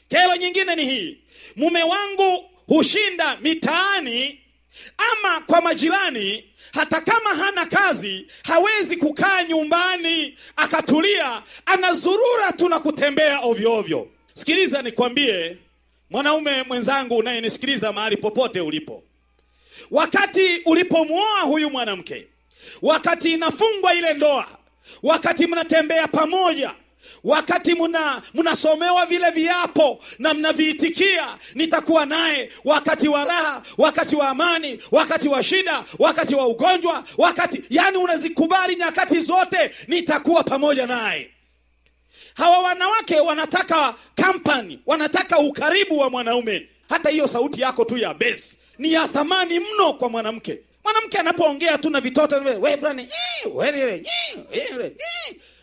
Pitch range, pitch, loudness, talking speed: 280-355 Hz, 320 Hz, -19 LUFS, 105 wpm